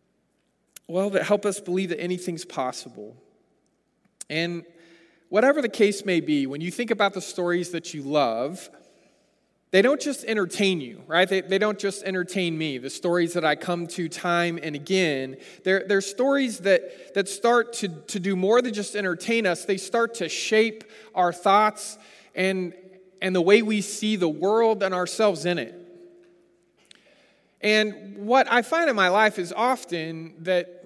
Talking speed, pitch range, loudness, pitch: 175 wpm, 175-215 Hz, -24 LUFS, 190 Hz